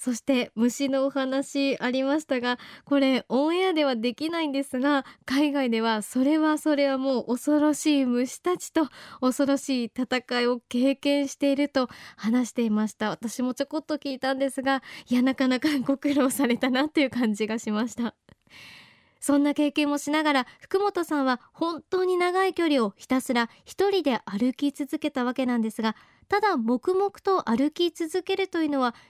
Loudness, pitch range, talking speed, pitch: -26 LUFS, 250-300 Hz, 340 characters per minute, 270 Hz